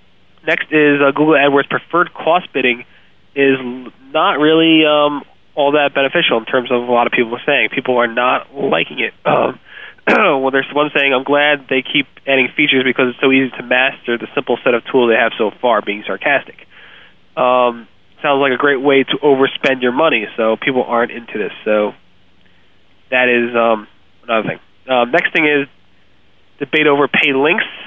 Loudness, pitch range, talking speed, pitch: -14 LUFS, 120-145 Hz, 185 wpm, 130 Hz